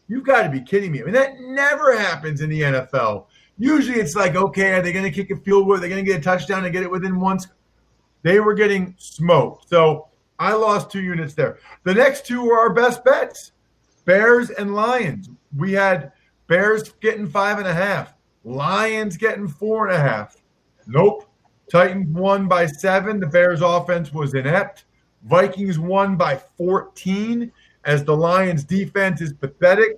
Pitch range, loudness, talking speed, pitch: 175-210 Hz, -19 LUFS, 185 wpm, 190 Hz